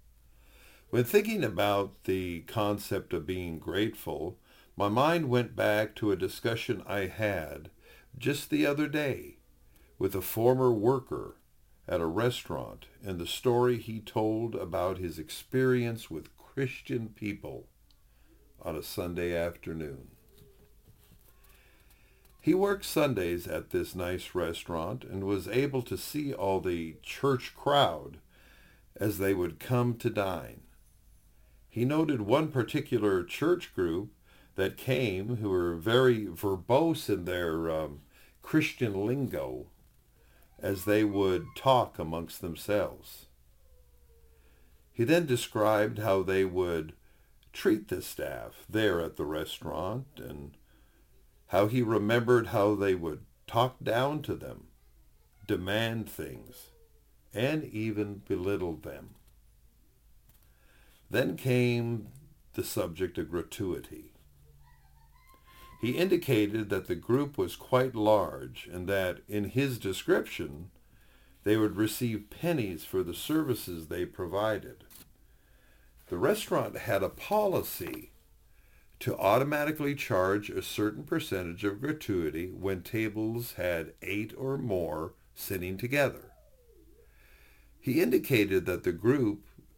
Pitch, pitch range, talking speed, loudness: 105 Hz, 90-125 Hz, 115 wpm, -31 LUFS